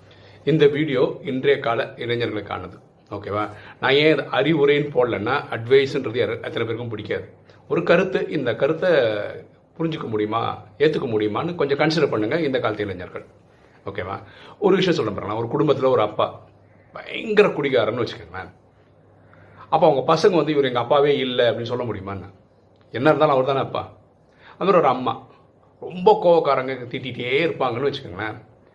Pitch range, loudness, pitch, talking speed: 105-150 Hz, -21 LUFS, 125 Hz, 130 wpm